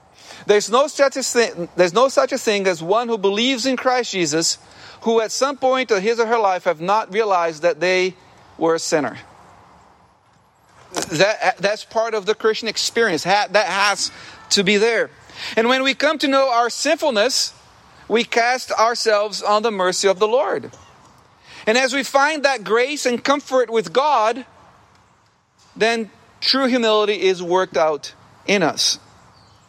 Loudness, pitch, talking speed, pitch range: -18 LUFS, 225 Hz, 165 wpm, 195-260 Hz